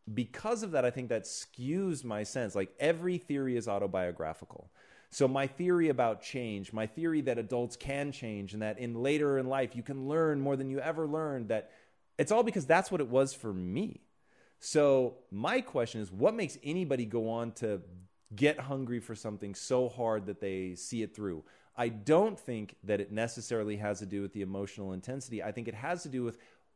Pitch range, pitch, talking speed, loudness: 105-140 Hz, 120 Hz, 200 wpm, -34 LUFS